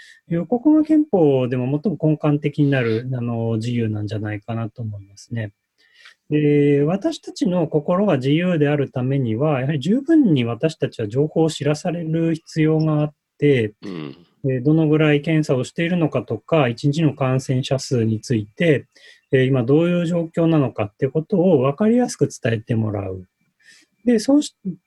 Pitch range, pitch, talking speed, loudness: 120-165 Hz, 145 Hz, 325 characters per minute, -20 LUFS